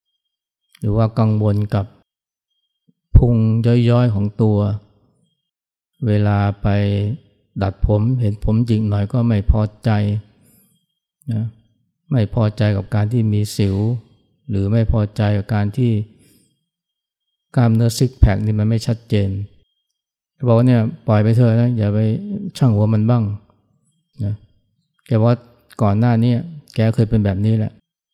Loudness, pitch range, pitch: -18 LUFS, 105-120 Hz, 110 Hz